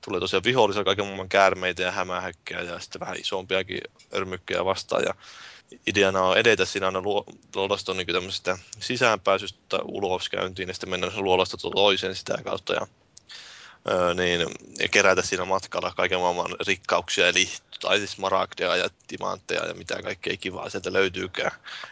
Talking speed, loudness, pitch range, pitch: 145 wpm, -25 LUFS, 90-95 Hz, 95 Hz